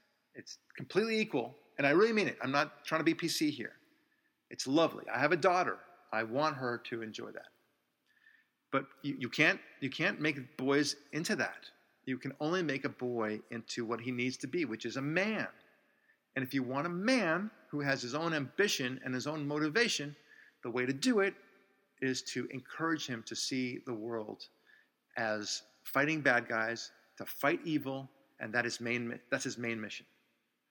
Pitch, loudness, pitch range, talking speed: 135 Hz, -34 LUFS, 120-155 Hz, 190 wpm